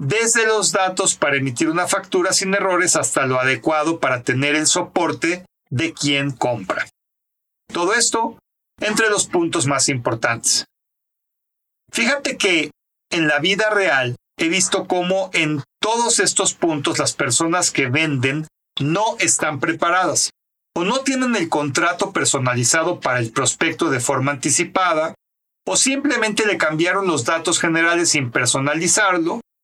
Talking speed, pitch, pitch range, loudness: 135 wpm, 165 Hz, 145-195 Hz, -18 LUFS